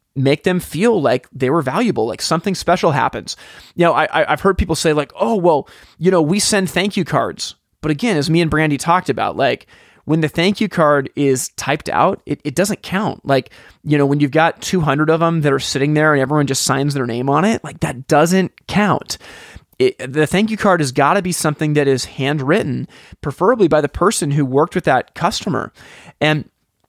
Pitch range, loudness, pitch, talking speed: 145-180 Hz, -16 LUFS, 155 Hz, 215 wpm